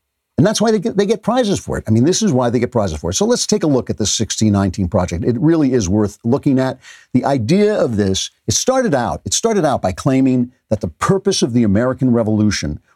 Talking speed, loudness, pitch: 250 wpm, -16 LUFS, 125 Hz